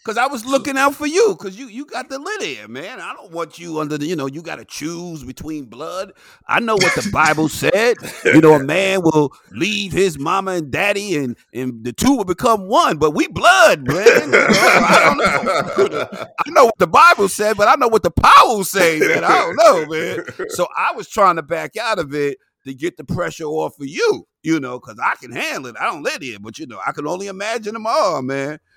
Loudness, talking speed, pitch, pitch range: -16 LUFS, 240 wpm, 180 Hz, 155-240 Hz